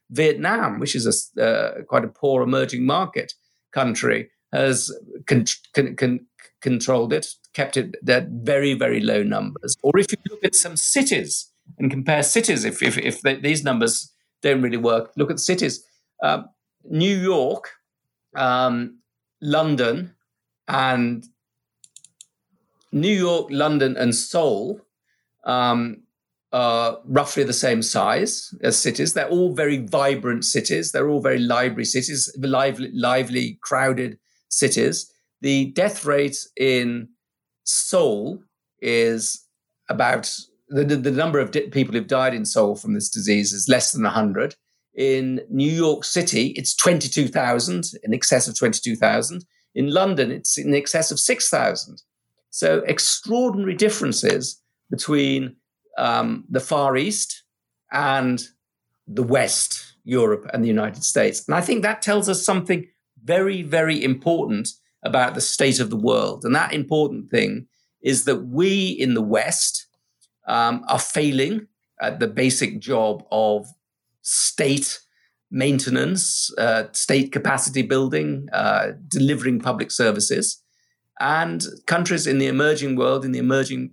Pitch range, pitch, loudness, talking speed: 125-155 Hz, 135 Hz, -21 LUFS, 135 wpm